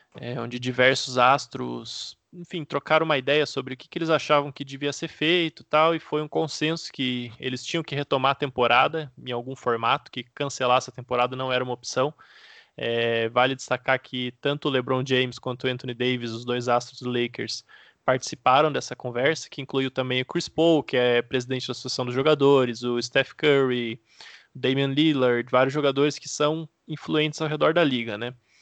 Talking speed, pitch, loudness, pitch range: 190 wpm, 130 Hz, -24 LUFS, 125-150 Hz